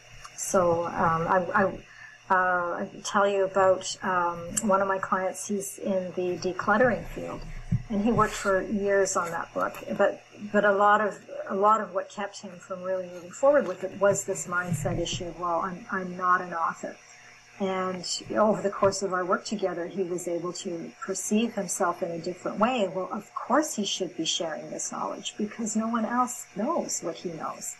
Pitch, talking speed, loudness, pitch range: 190 Hz, 195 wpm, -27 LUFS, 180-205 Hz